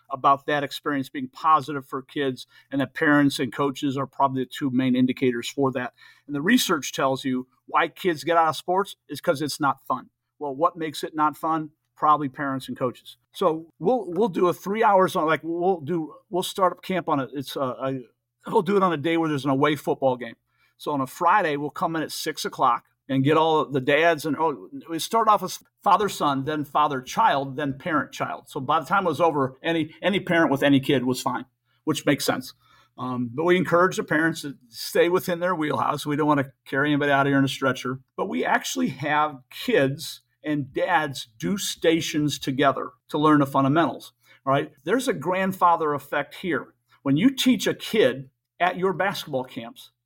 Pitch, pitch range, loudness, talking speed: 150 Hz, 135-170 Hz, -24 LUFS, 210 wpm